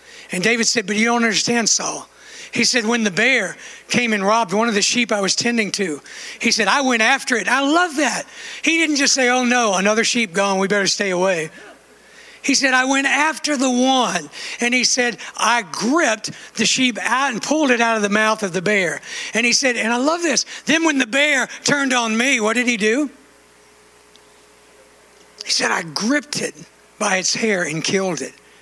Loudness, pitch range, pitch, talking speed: -17 LUFS, 195-260 Hz, 230 Hz, 210 wpm